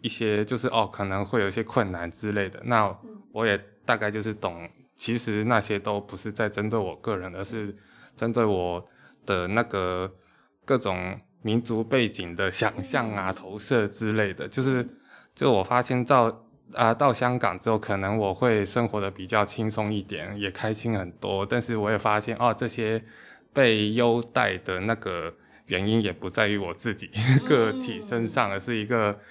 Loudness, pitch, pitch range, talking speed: -26 LUFS, 110 Hz, 100-115 Hz, 250 characters per minute